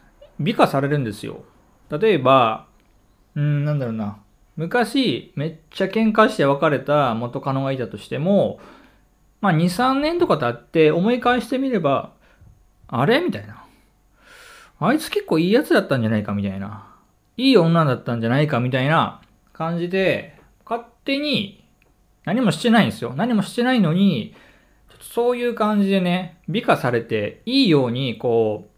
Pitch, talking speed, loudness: 170 Hz, 310 characters per minute, -20 LUFS